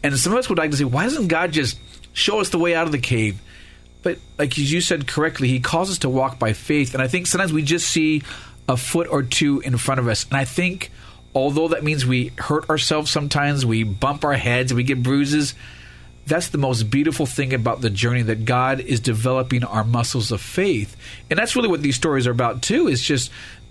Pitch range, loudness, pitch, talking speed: 120-155 Hz, -20 LUFS, 135 Hz, 230 wpm